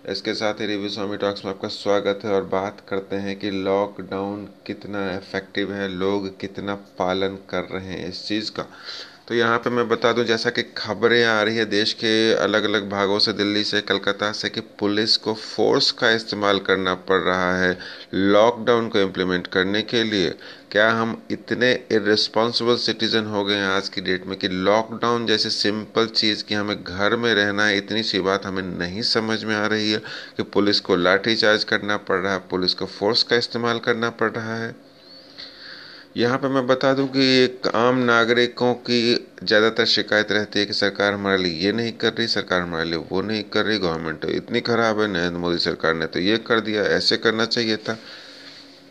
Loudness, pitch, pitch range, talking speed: -21 LUFS, 105 Hz, 100-115 Hz, 200 wpm